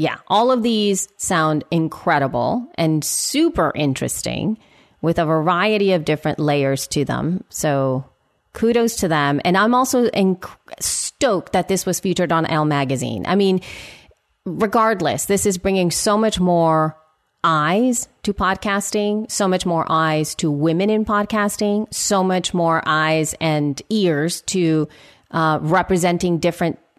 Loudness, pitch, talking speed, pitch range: -19 LUFS, 175 Hz, 140 wpm, 155-205 Hz